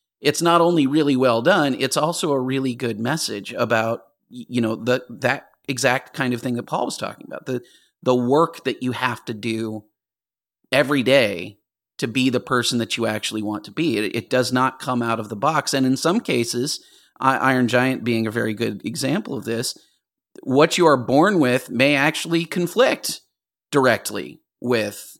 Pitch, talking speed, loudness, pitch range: 125 Hz, 185 wpm, -21 LUFS, 115-140 Hz